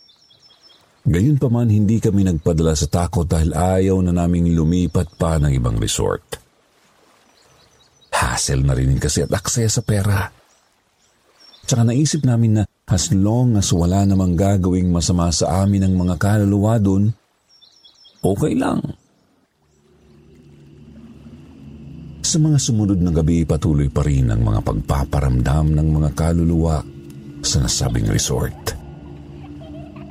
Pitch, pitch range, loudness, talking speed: 85 Hz, 75-105 Hz, -18 LUFS, 120 wpm